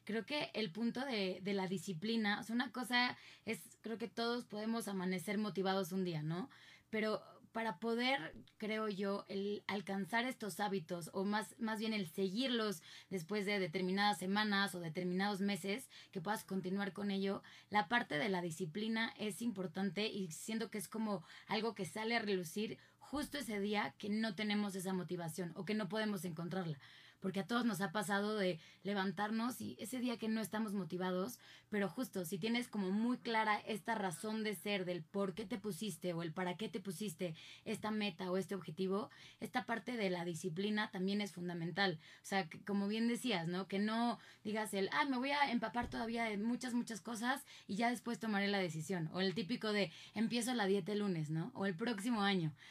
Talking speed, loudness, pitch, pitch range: 195 wpm, -40 LUFS, 205 Hz, 190-225 Hz